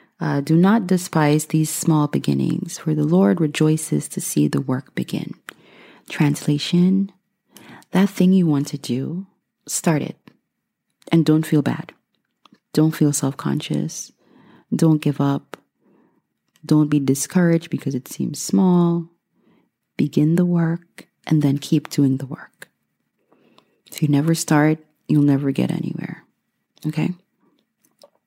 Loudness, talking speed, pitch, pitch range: -20 LUFS, 130 wpm, 155 Hz, 145-175 Hz